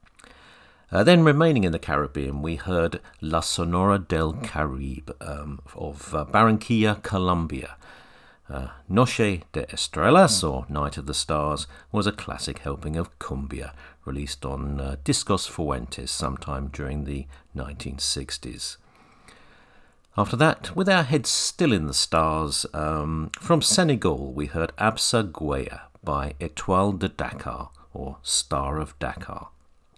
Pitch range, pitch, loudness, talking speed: 70-95 Hz, 75 Hz, -24 LUFS, 130 wpm